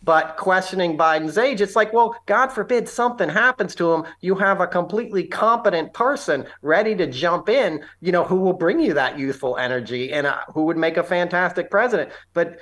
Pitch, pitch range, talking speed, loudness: 180 Hz, 165-205 Hz, 195 wpm, -20 LUFS